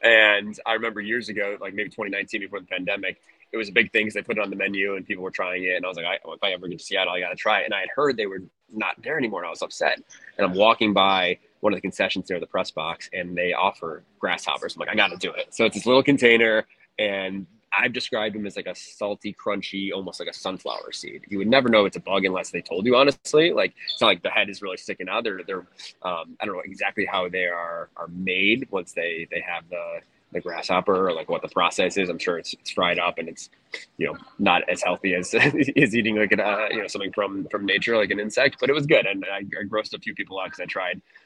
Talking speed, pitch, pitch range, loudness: 275 wpm, 105 Hz, 95-115 Hz, -23 LUFS